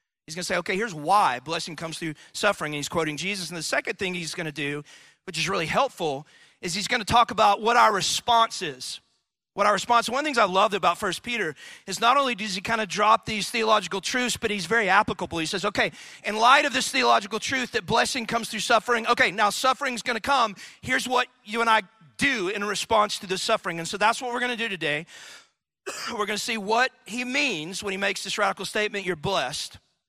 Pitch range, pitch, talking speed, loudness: 185-235 Hz, 210 Hz, 225 wpm, -24 LUFS